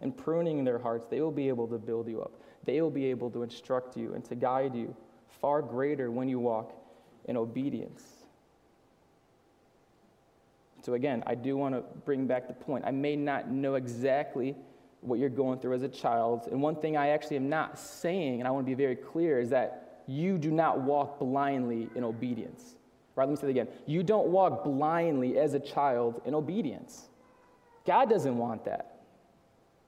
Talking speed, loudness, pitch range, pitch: 190 wpm, -31 LUFS, 125-145 Hz, 135 Hz